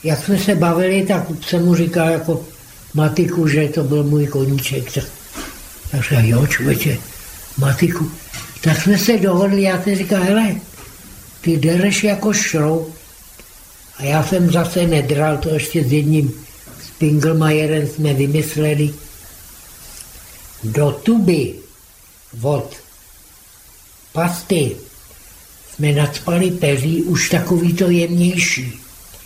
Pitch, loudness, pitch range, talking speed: 155 Hz, -16 LUFS, 140-175 Hz, 115 wpm